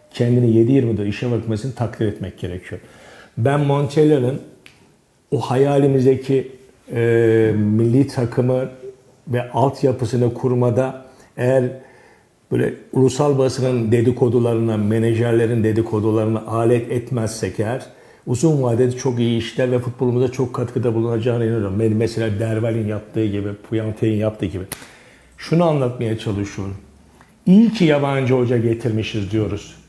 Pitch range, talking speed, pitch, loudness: 110-130 Hz, 110 wpm, 120 Hz, -19 LUFS